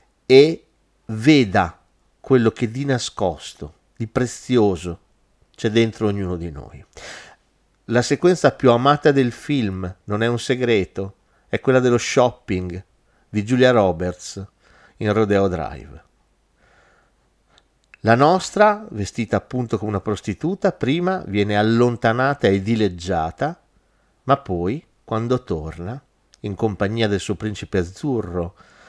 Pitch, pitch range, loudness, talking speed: 110 Hz, 95-125 Hz, -20 LUFS, 115 wpm